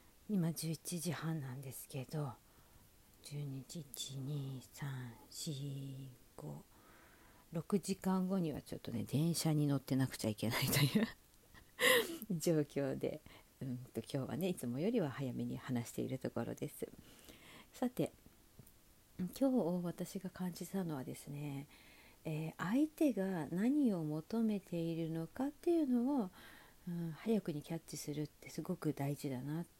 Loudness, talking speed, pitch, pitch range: -39 LUFS, 250 characters per minute, 155 Hz, 135-185 Hz